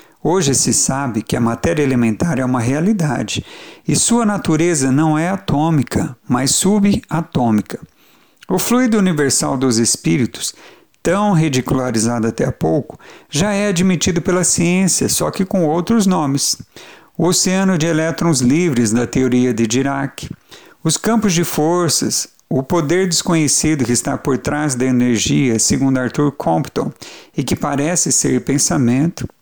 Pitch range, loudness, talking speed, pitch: 130-175 Hz, -16 LUFS, 140 wpm, 150 Hz